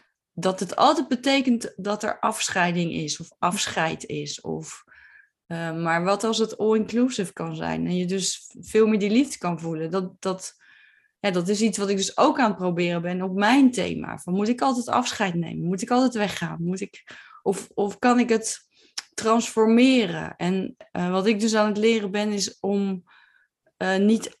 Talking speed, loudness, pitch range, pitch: 190 wpm, -24 LUFS, 180-225 Hz, 200 Hz